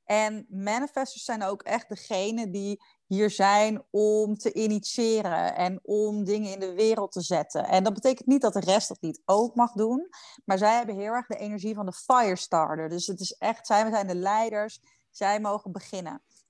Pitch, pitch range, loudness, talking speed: 210 Hz, 195-225 Hz, -27 LUFS, 195 wpm